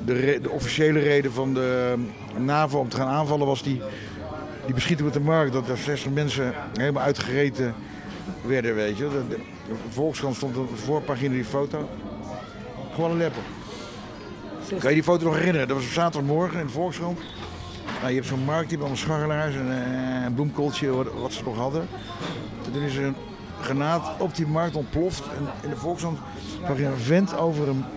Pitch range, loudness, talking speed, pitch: 125-155 Hz, -26 LUFS, 185 wpm, 135 Hz